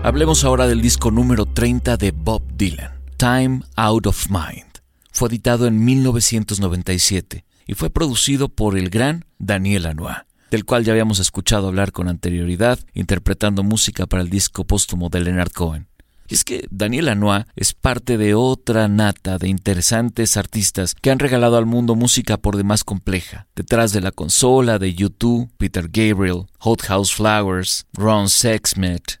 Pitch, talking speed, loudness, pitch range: 105 Hz, 160 wpm, -17 LUFS, 95-120 Hz